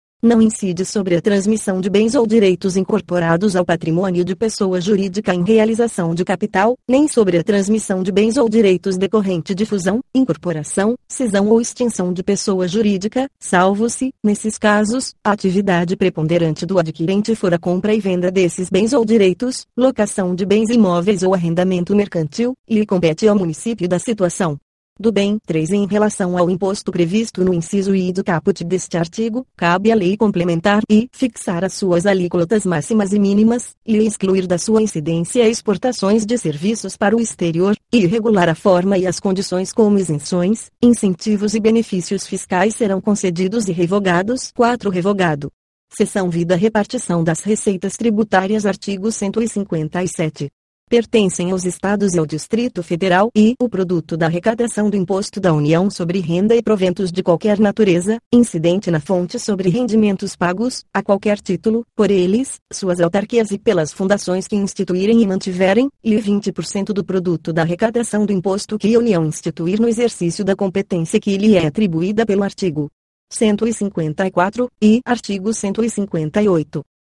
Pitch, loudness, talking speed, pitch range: 200 Hz, -17 LUFS, 155 wpm, 180-220 Hz